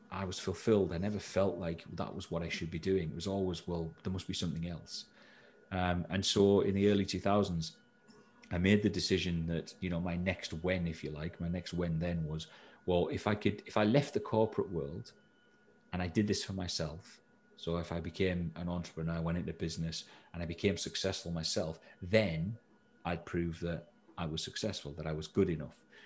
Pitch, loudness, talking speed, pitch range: 85 Hz, -35 LUFS, 210 wpm, 85-95 Hz